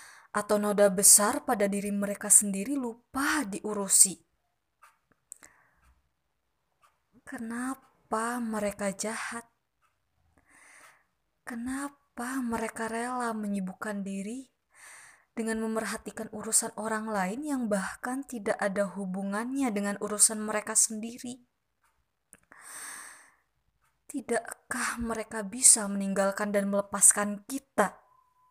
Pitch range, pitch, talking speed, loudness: 205-245 Hz, 220 Hz, 80 wpm, -27 LUFS